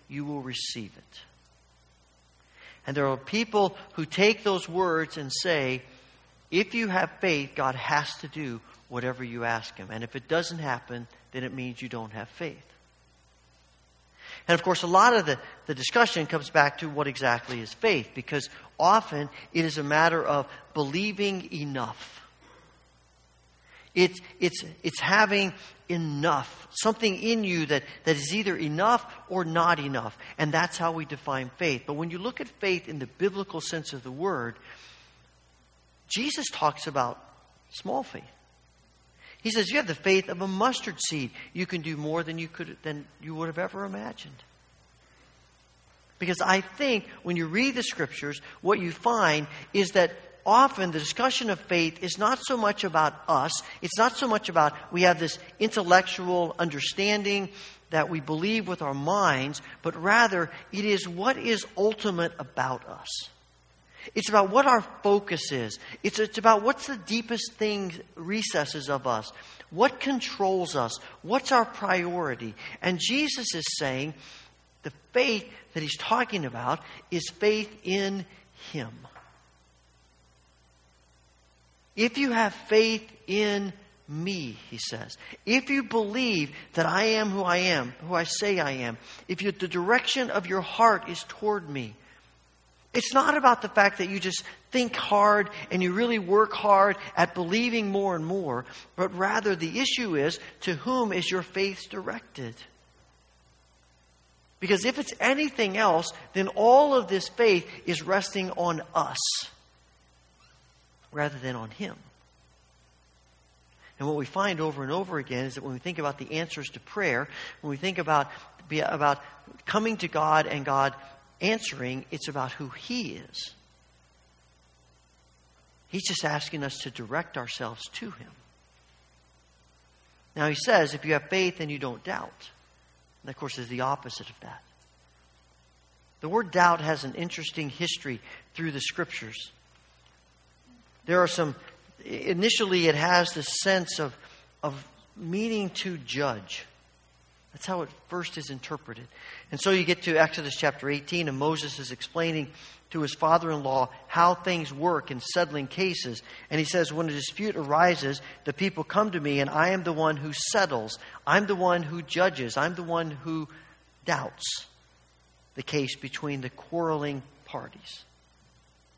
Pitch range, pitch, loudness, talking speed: 125-190 Hz, 160 Hz, -27 LUFS, 155 wpm